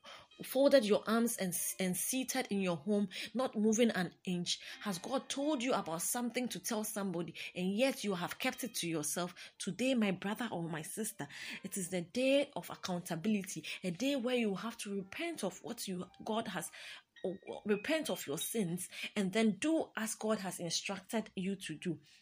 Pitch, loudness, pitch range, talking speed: 205 Hz, -36 LUFS, 180-240 Hz, 185 wpm